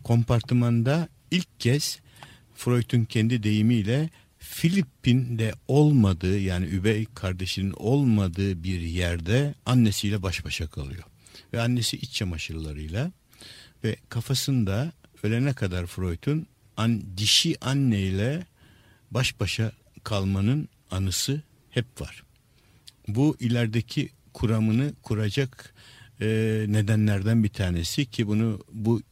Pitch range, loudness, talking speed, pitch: 100-125 Hz, -26 LUFS, 95 wpm, 115 Hz